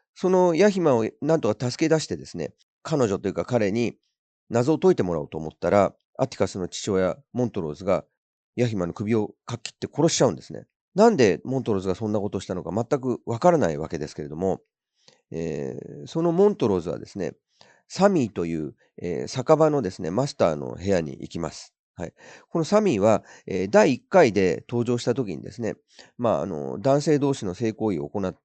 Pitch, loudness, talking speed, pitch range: 120 Hz, -24 LUFS, 395 characters per minute, 95-155 Hz